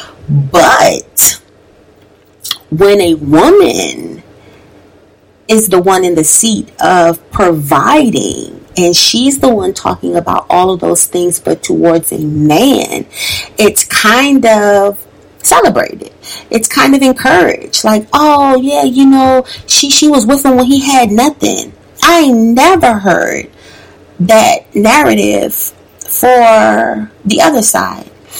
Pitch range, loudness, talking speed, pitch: 180-275 Hz, -8 LUFS, 120 wpm, 230 Hz